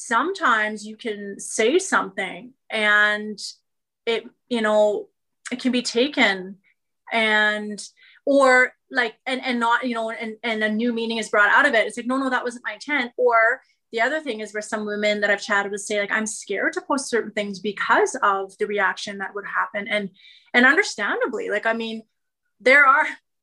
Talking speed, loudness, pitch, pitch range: 190 wpm, -21 LUFS, 225 Hz, 210-250 Hz